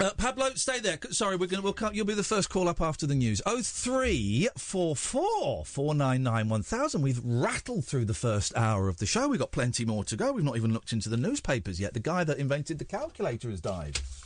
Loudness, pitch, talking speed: -29 LUFS, 140 Hz, 245 wpm